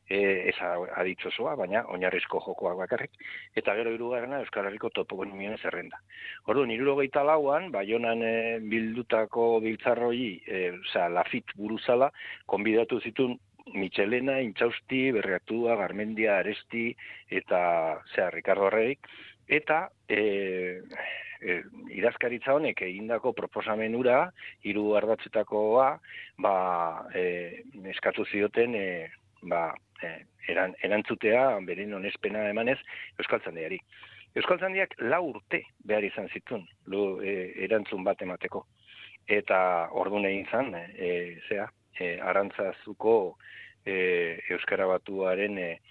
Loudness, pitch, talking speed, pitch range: -29 LUFS, 110 Hz, 105 wpm, 100-125 Hz